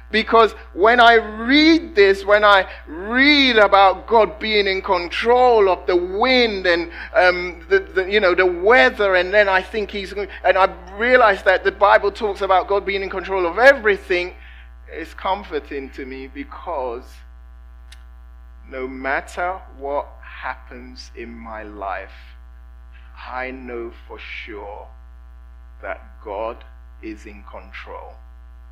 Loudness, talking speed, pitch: -16 LUFS, 135 wpm, 185 Hz